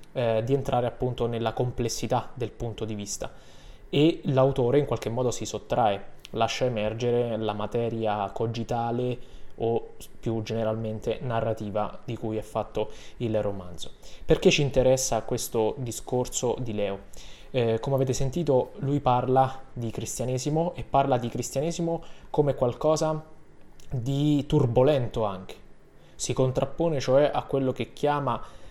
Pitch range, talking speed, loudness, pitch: 110-135 Hz, 130 wpm, -27 LUFS, 125 Hz